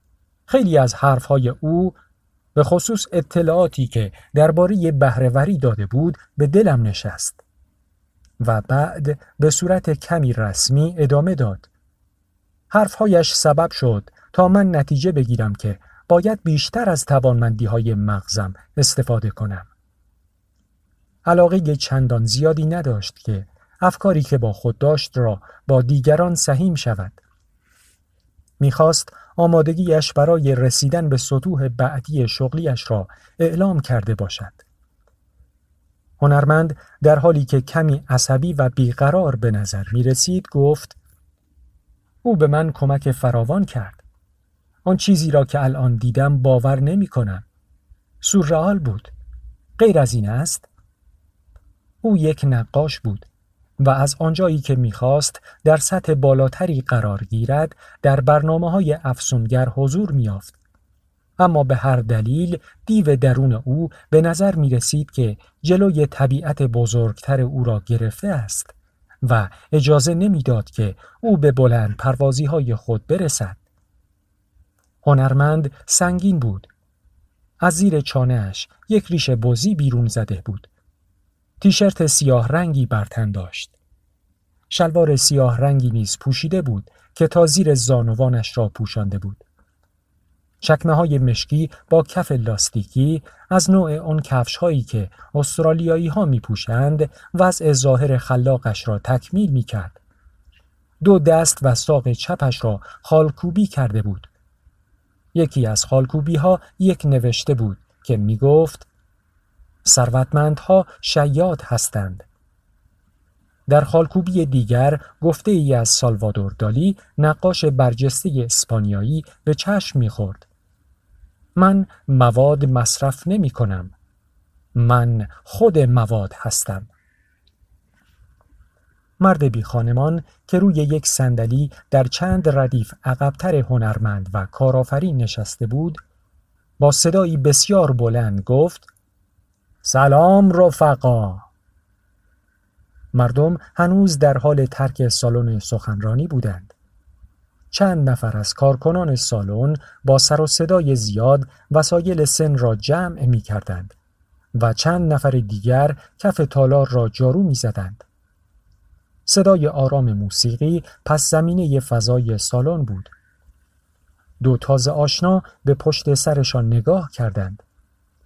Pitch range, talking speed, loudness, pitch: 100-155 Hz, 115 wpm, -18 LUFS, 130 Hz